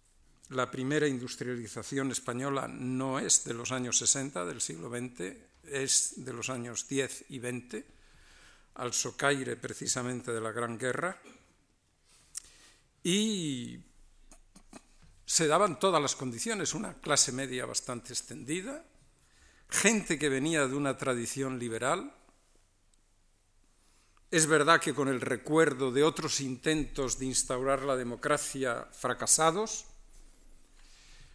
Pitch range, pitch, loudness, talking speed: 120-145 Hz, 130 Hz, -30 LUFS, 115 wpm